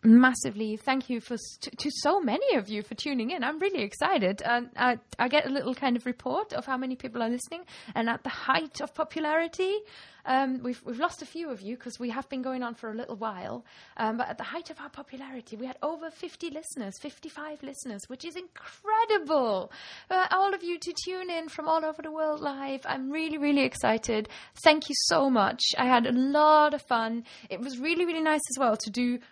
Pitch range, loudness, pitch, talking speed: 240-315 Hz, -28 LUFS, 270 Hz, 225 wpm